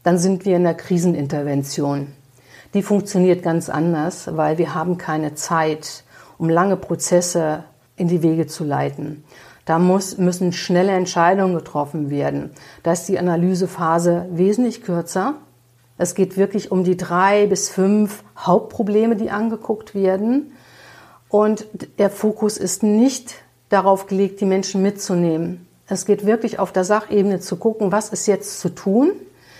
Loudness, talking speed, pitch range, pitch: -19 LUFS, 145 wpm, 165-200 Hz, 185 Hz